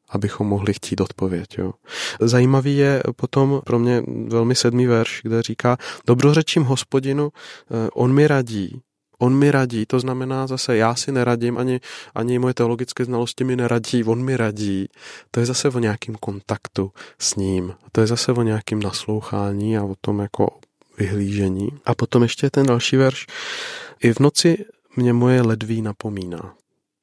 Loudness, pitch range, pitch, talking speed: -20 LUFS, 110-130 Hz, 120 Hz, 160 wpm